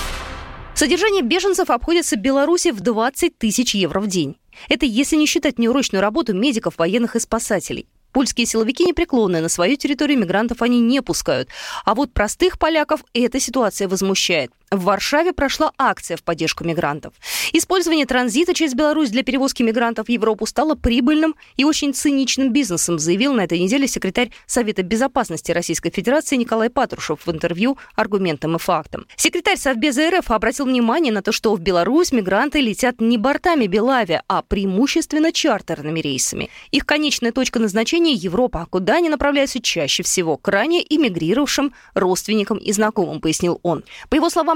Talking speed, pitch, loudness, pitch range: 155 wpm, 240 Hz, -18 LUFS, 195-295 Hz